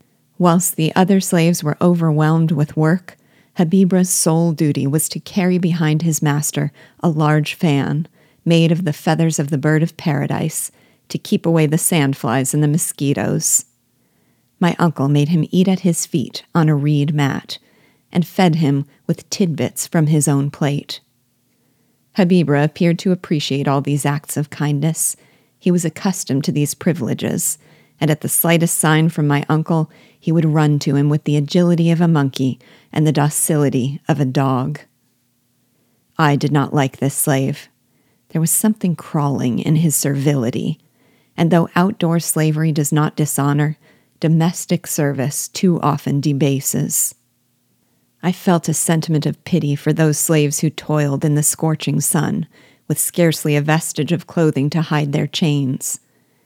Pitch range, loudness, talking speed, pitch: 145-170 Hz, -17 LUFS, 155 wpm, 155 Hz